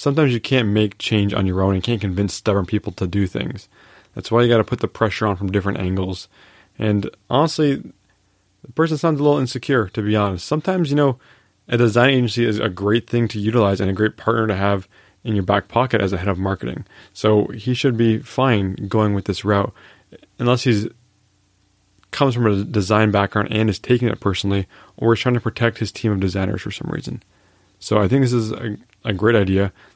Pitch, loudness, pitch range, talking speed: 105 Hz, -19 LUFS, 100-120 Hz, 220 wpm